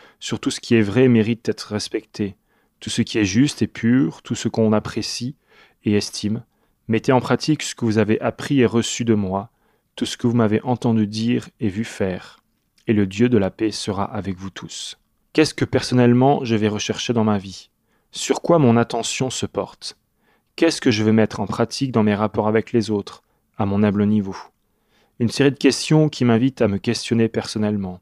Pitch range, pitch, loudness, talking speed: 105-120 Hz, 115 Hz, -20 LUFS, 210 wpm